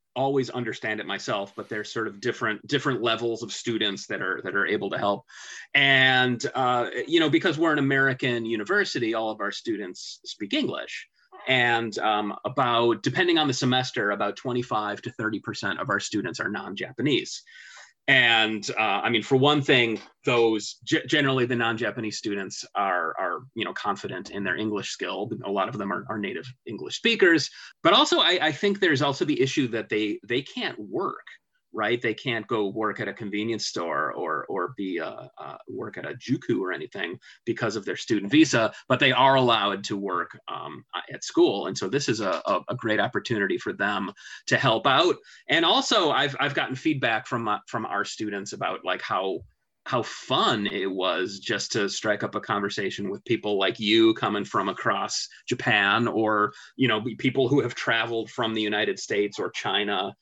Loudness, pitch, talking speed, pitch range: -25 LUFS, 115 Hz, 185 wpm, 110-135 Hz